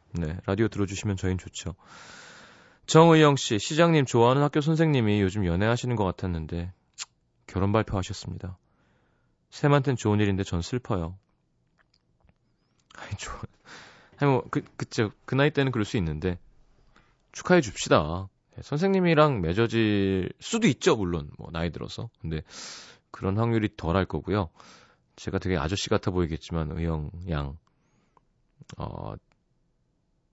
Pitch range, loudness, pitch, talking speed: 85-125 Hz, -26 LUFS, 100 Hz, 280 characters per minute